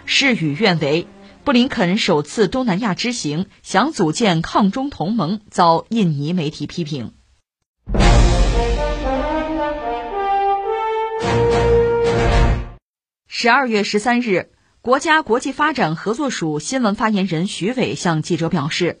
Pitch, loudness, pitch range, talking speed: 200 Hz, -18 LUFS, 160-250 Hz, 175 characters per minute